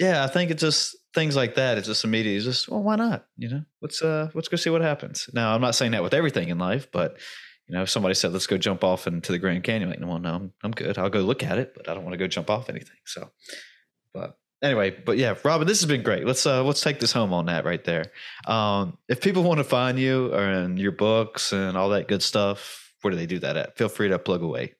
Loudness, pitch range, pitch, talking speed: -24 LUFS, 100-155 Hz, 120 Hz, 280 wpm